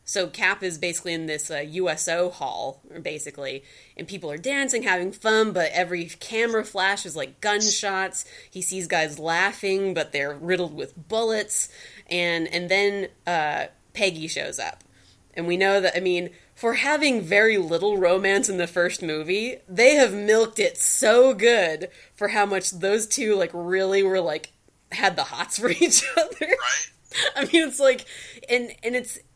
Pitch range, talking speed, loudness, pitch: 175-220 Hz, 170 wpm, -23 LUFS, 190 Hz